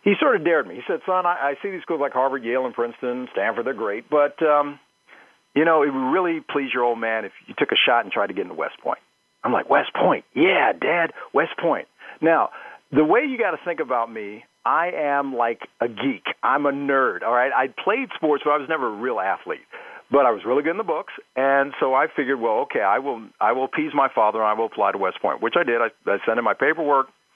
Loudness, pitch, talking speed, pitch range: -22 LUFS, 140 Hz, 255 wpm, 125-160 Hz